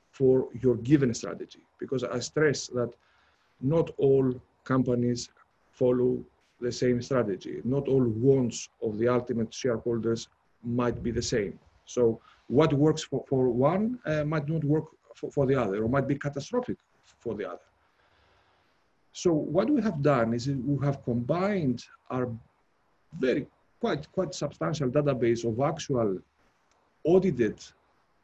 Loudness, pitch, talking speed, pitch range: -28 LUFS, 130 Hz, 140 wpm, 120-150 Hz